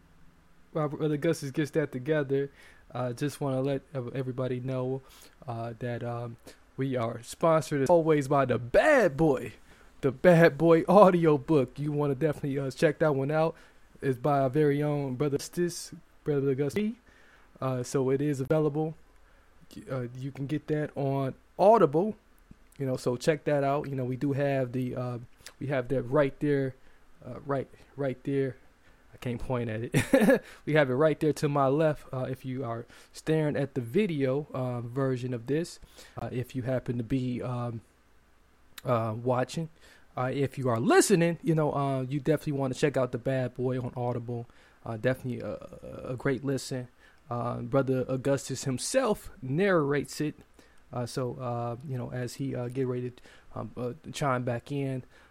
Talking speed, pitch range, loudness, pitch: 175 wpm, 125-150 Hz, -29 LUFS, 135 Hz